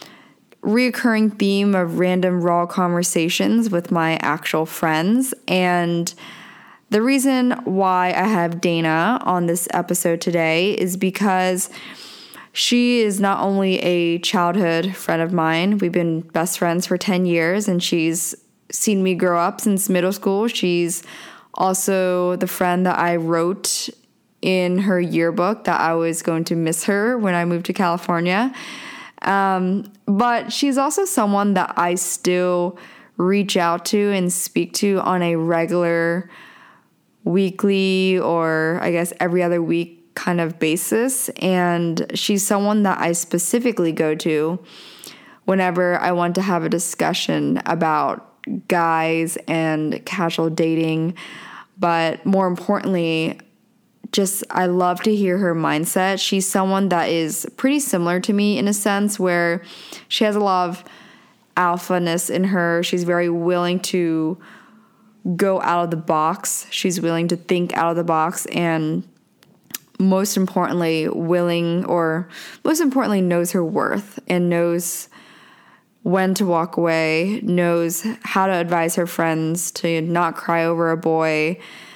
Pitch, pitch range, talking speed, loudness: 180 Hz, 170-195 Hz, 140 wpm, -19 LUFS